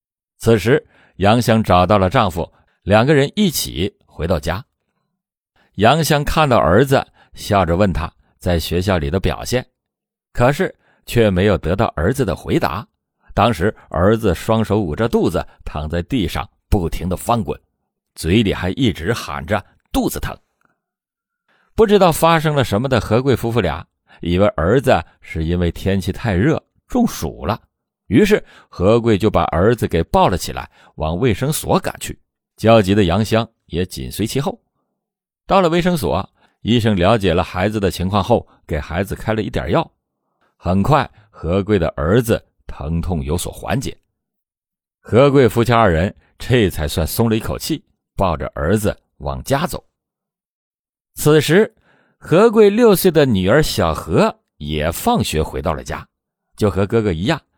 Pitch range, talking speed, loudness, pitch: 85-120 Hz, 225 characters per minute, -17 LUFS, 105 Hz